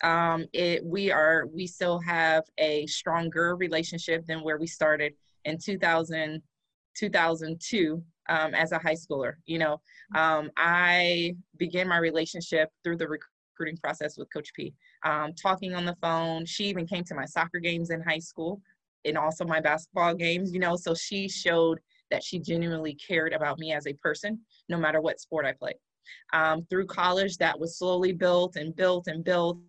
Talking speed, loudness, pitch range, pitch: 180 wpm, -28 LUFS, 160-180 Hz, 165 Hz